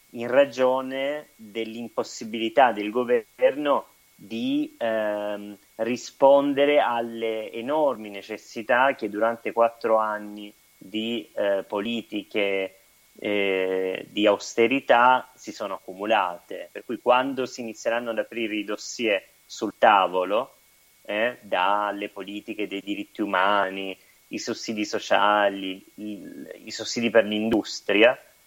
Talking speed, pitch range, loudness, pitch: 105 wpm, 105-120 Hz, -24 LUFS, 110 Hz